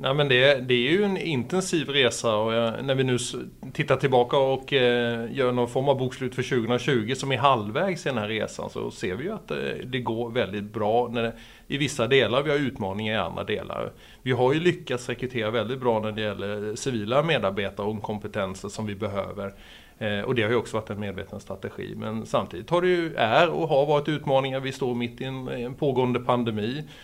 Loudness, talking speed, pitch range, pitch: -25 LUFS, 205 wpm, 110-135 Hz, 125 Hz